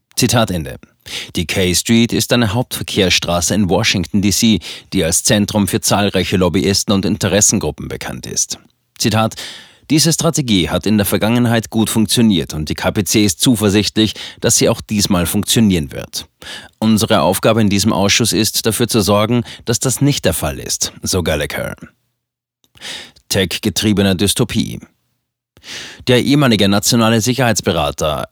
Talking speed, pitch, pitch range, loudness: 135 wpm, 105 Hz, 100-115 Hz, -14 LUFS